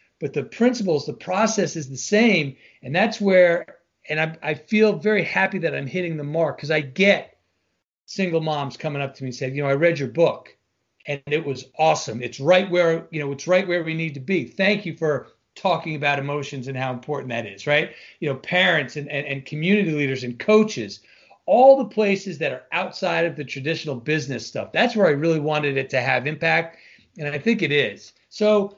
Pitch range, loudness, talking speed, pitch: 140-185 Hz, -22 LUFS, 215 wpm, 160 Hz